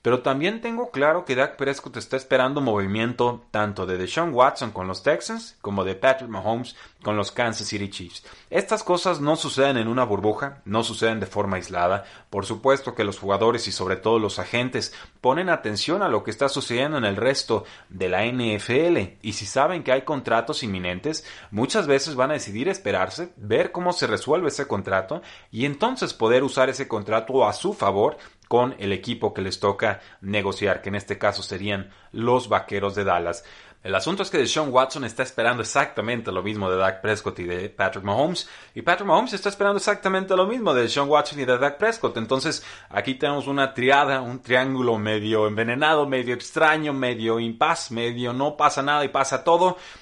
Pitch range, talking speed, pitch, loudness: 105-140 Hz, 190 wpm, 120 Hz, -23 LUFS